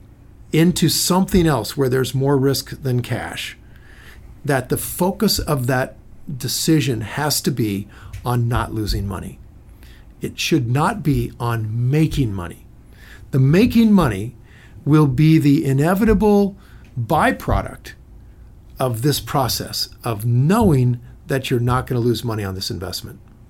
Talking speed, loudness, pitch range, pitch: 135 wpm, -19 LUFS, 110-150 Hz, 130 Hz